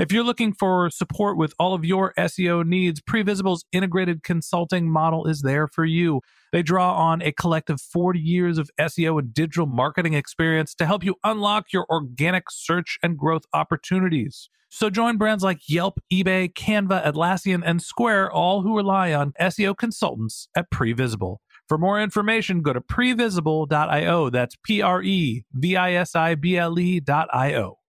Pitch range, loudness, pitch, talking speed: 160-190 Hz, -22 LUFS, 175 Hz, 165 wpm